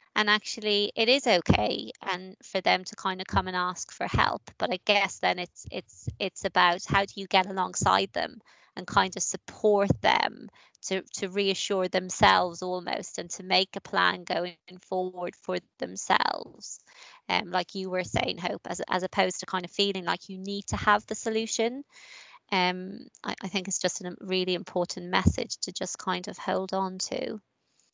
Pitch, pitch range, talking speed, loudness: 190 Hz, 180-200 Hz, 185 wpm, -28 LUFS